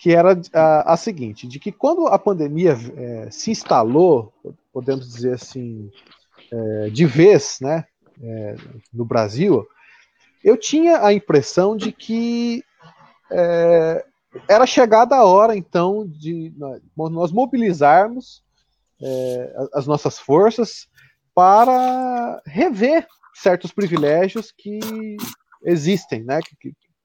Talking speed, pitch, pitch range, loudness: 115 wpm, 170 Hz, 135-220 Hz, -17 LUFS